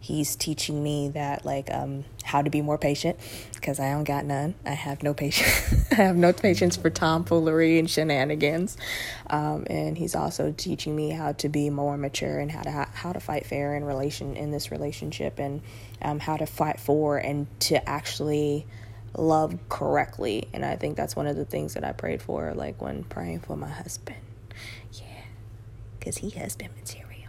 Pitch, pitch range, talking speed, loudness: 145 Hz, 110-150 Hz, 190 wpm, -27 LUFS